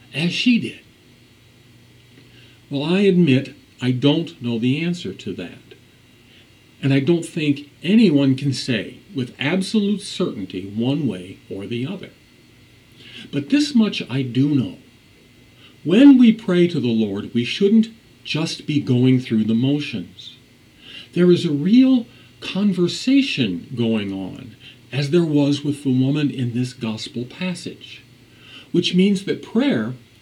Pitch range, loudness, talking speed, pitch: 120-175 Hz, -19 LUFS, 135 wpm, 135 Hz